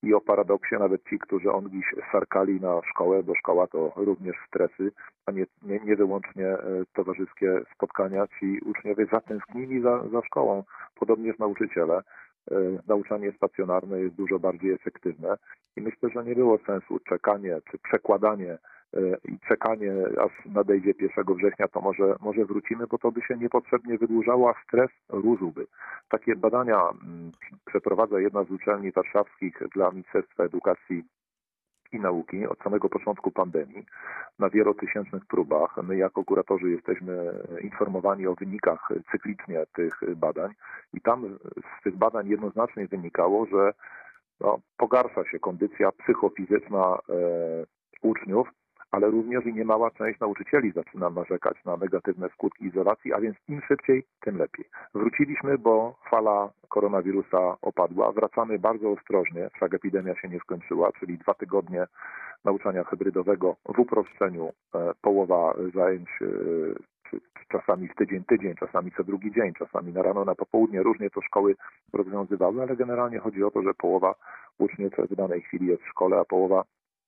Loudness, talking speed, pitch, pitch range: -27 LUFS, 145 wpm, 100 Hz, 95-110 Hz